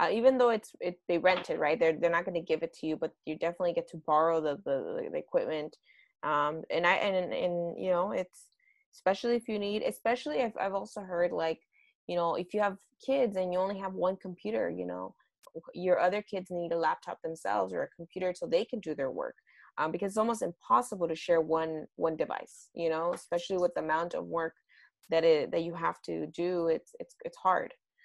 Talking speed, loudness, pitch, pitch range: 225 wpm, -32 LUFS, 180 Hz, 165-235 Hz